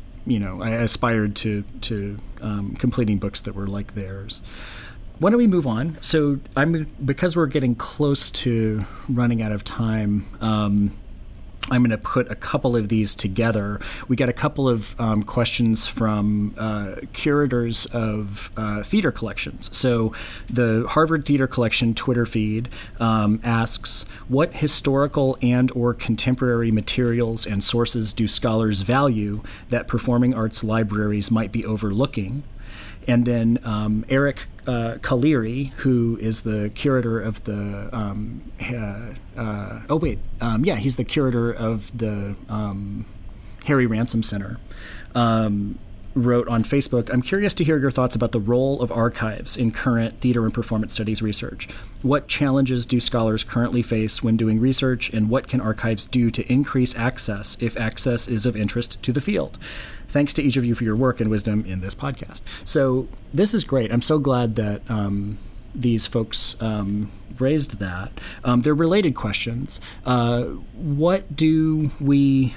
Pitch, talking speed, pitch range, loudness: 115 Hz, 155 wpm, 105-125 Hz, -22 LUFS